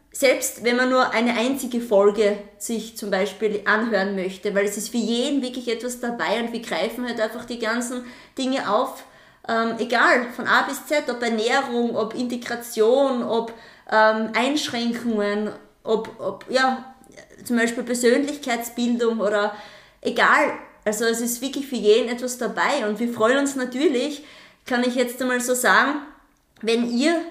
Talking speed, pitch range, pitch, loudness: 155 wpm, 220-250 Hz, 235 Hz, -22 LUFS